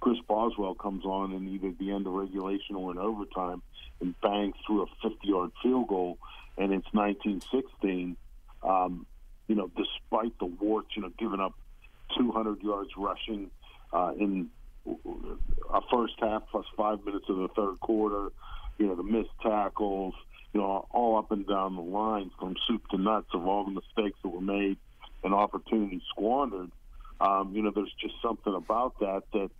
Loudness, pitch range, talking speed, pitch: -31 LUFS, 95-105 Hz, 175 wpm, 100 Hz